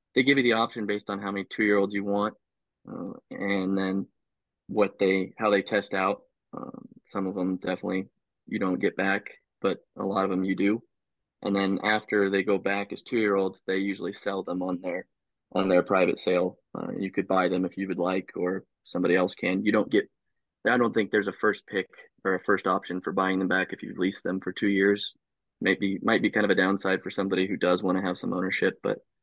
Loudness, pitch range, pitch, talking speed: -27 LUFS, 95-100 Hz, 95 Hz, 225 wpm